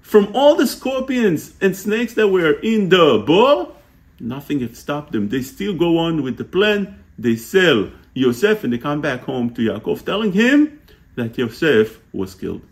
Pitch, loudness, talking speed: 160 Hz, -18 LUFS, 180 wpm